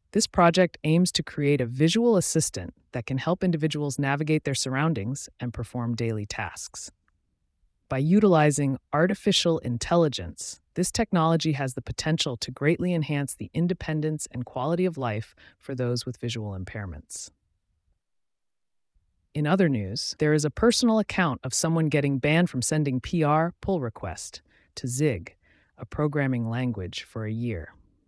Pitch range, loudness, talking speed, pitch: 120-160 Hz, -25 LUFS, 145 wpm, 140 Hz